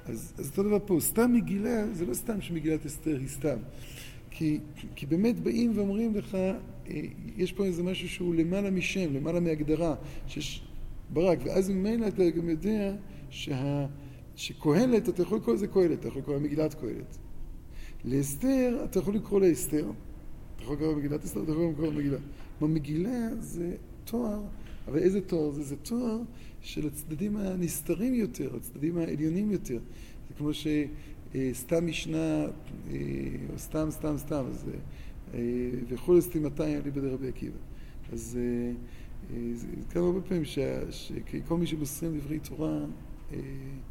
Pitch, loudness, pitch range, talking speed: 155 Hz, -31 LUFS, 135-185 Hz, 140 wpm